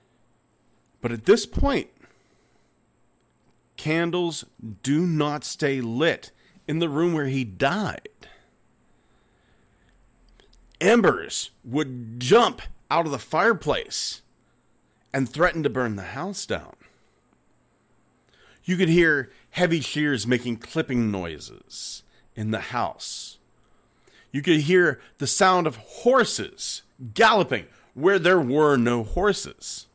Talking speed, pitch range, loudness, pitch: 105 wpm, 120-170 Hz, -23 LUFS, 135 Hz